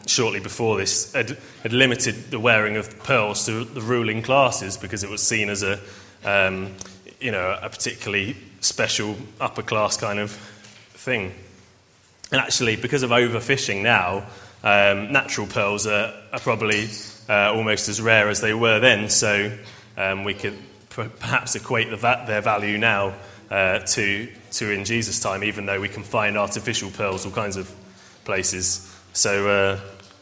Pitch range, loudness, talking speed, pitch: 100-115 Hz, -21 LUFS, 160 wpm, 105 Hz